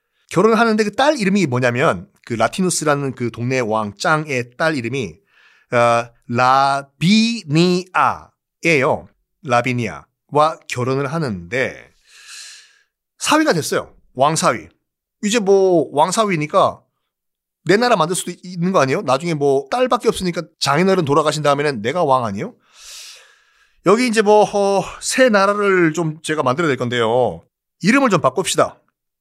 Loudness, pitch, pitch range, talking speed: -17 LUFS, 170 Hz, 135-220 Hz, 285 characters per minute